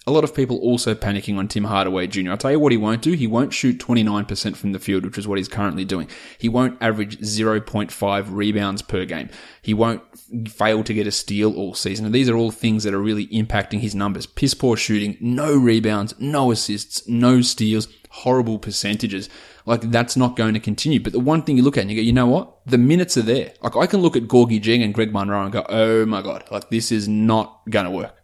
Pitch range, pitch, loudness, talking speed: 105-120 Hz, 110 Hz, -20 LUFS, 240 wpm